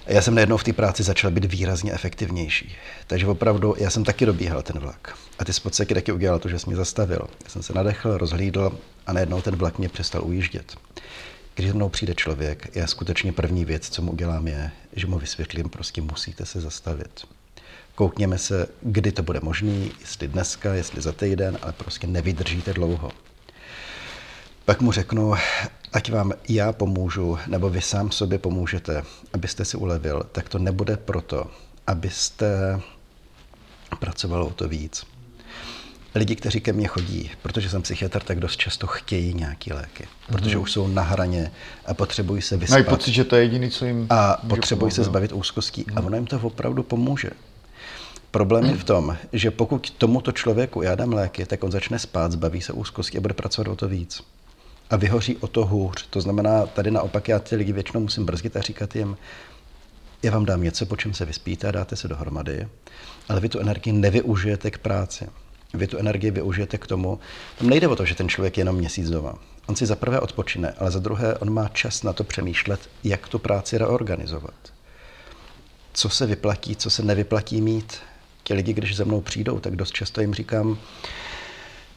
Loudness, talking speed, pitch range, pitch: -24 LUFS, 180 wpm, 90-110 Hz, 100 Hz